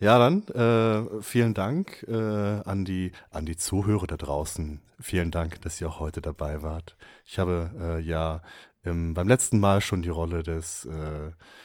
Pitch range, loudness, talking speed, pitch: 80-105 Hz, -27 LUFS, 165 wpm, 90 Hz